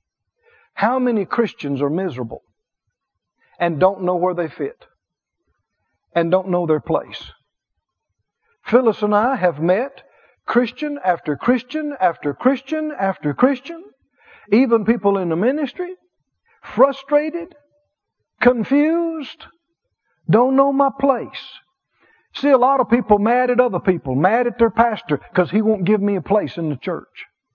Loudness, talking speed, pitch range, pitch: -18 LUFS, 135 wpm, 185-280 Hz, 235 Hz